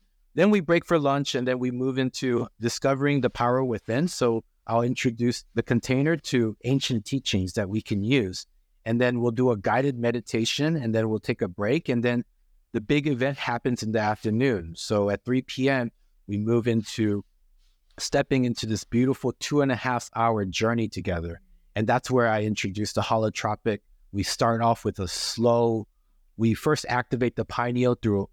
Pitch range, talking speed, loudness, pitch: 110-130 Hz, 180 wpm, -26 LUFS, 120 Hz